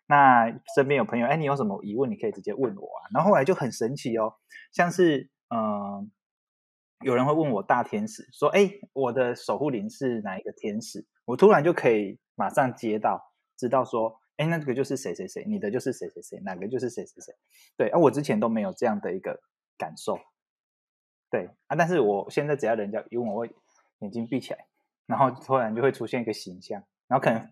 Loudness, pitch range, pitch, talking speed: -26 LUFS, 115-175 Hz, 135 Hz, 310 characters per minute